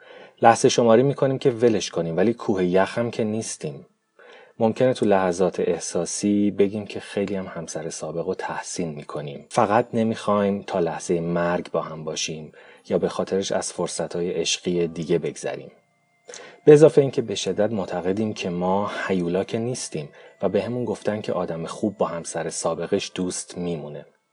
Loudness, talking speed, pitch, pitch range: -23 LUFS, 160 wpm, 100 Hz, 90-115 Hz